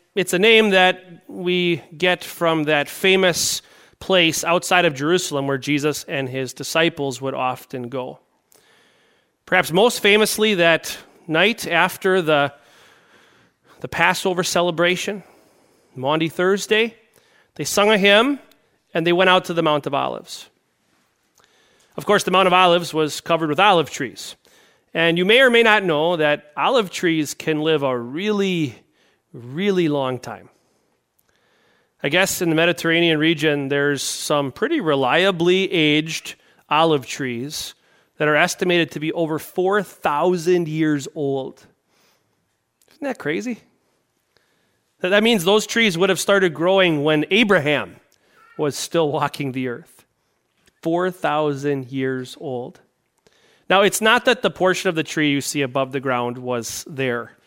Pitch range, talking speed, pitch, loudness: 145-185 Hz, 140 wpm, 165 Hz, -19 LUFS